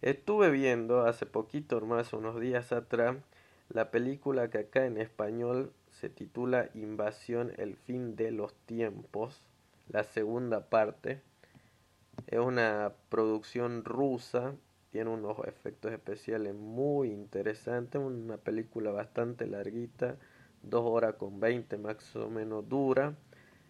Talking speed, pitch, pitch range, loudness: 120 wpm, 115 Hz, 110-125 Hz, -34 LUFS